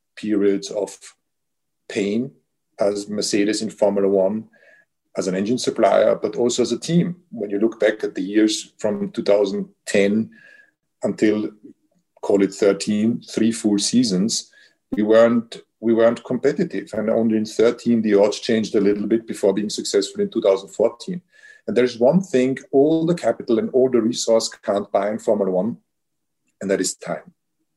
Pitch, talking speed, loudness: 115 Hz, 160 wpm, -20 LUFS